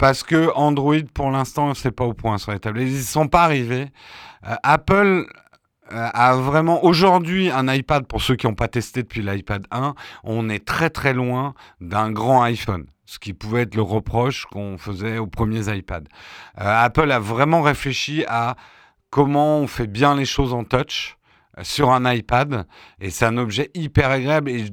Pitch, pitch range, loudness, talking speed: 125 Hz, 110-145 Hz, -20 LUFS, 185 wpm